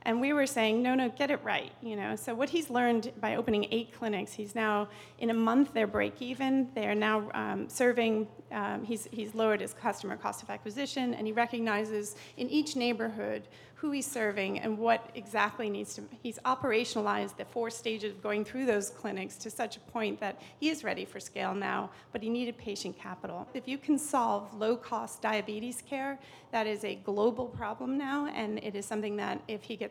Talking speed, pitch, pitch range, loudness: 205 wpm, 225 Hz, 215-250 Hz, -33 LUFS